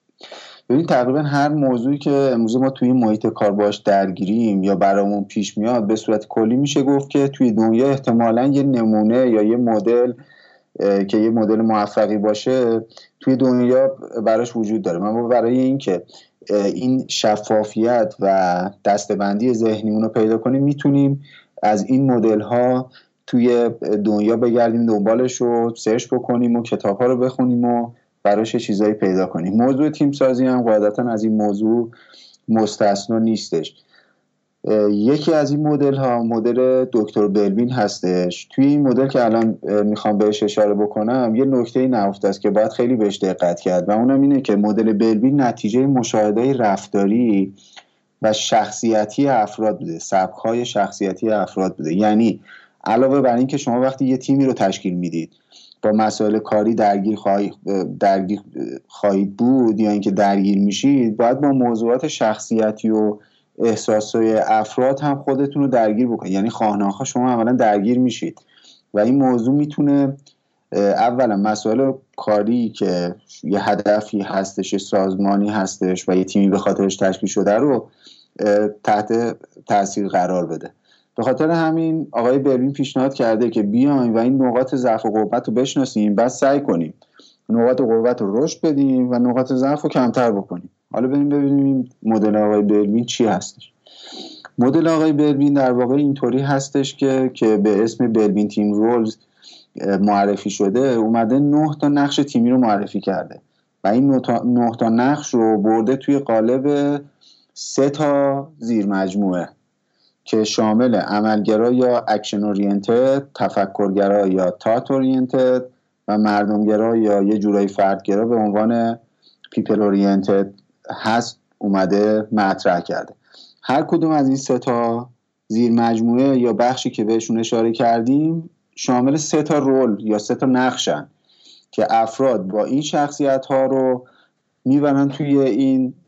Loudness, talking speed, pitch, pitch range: -18 LUFS, 145 wpm, 115 Hz, 105-130 Hz